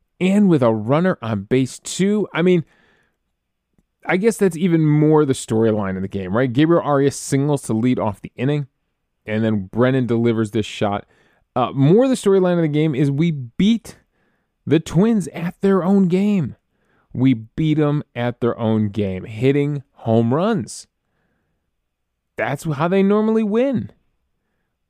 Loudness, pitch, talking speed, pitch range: -18 LUFS, 140 Hz, 155 wpm, 115-180 Hz